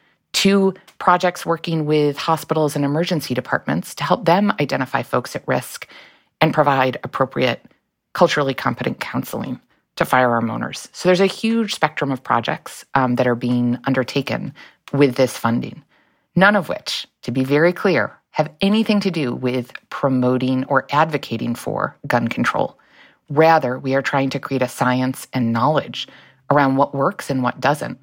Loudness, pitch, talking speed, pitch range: -19 LUFS, 140 Hz, 155 wpm, 125-160 Hz